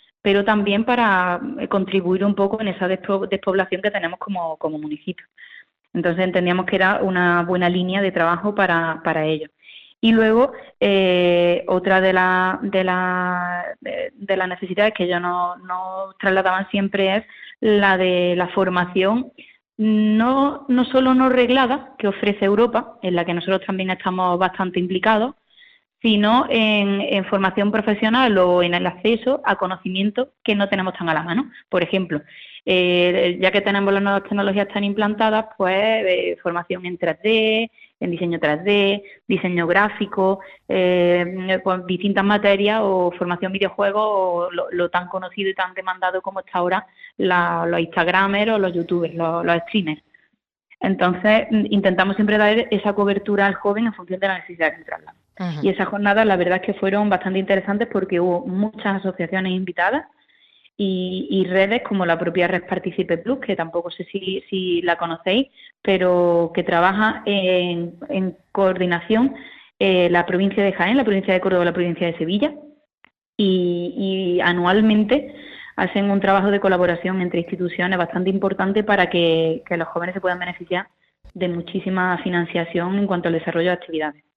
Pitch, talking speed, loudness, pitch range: 190 Hz, 160 wpm, -20 LUFS, 180-205 Hz